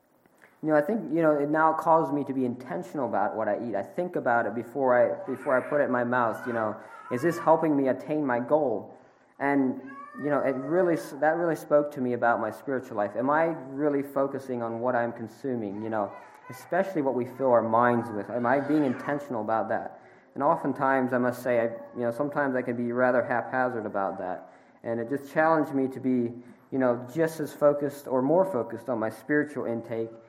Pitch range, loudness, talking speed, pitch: 120-150 Hz, -27 LUFS, 220 wpm, 130 Hz